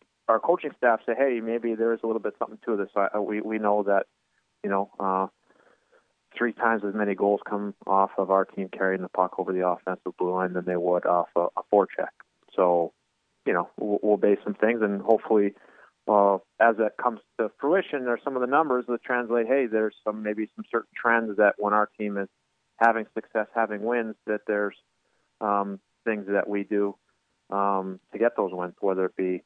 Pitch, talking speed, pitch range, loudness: 105 Hz, 205 wpm, 95-115 Hz, -26 LUFS